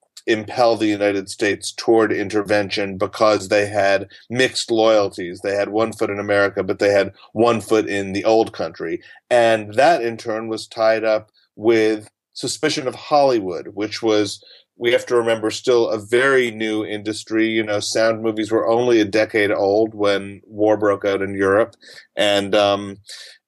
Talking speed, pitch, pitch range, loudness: 165 wpm, 110 Hz, 105-115 Hz, -19 LUFS